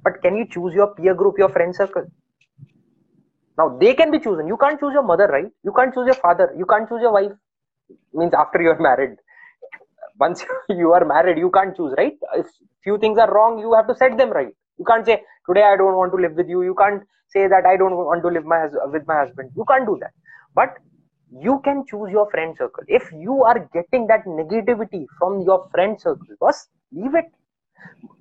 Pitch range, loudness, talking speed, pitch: 175-235 Hz, -18 LUFS, 220 wpm, 200 Hz